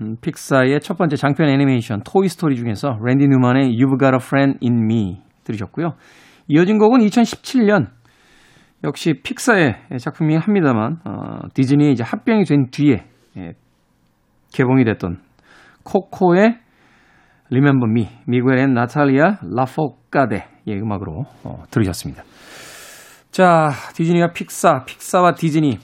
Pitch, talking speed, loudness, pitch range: 140 Hz, 315 characters per minute, -17 LUFS, 125-170 Hz